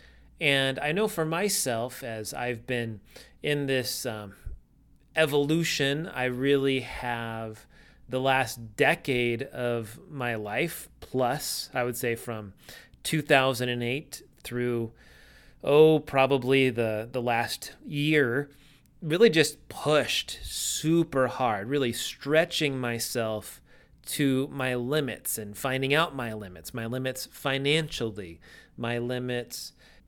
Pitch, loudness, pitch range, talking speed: 130 Hz, -27 LUFS, 115-145 Hz, 110 wpm